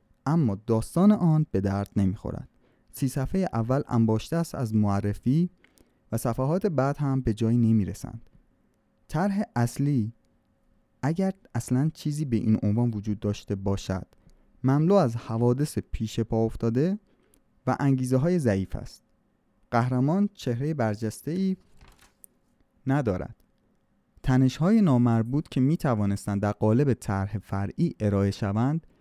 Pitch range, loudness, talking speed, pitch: 105-145 Hz, -26 LUFS, 120 wpm, 120 Hz